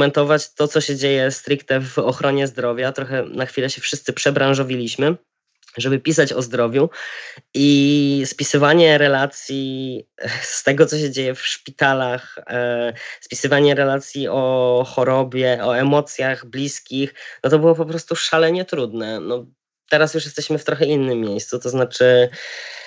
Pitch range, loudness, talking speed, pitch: 130-145 Hz, -18 LUFS, 135 wpm, 135 Hz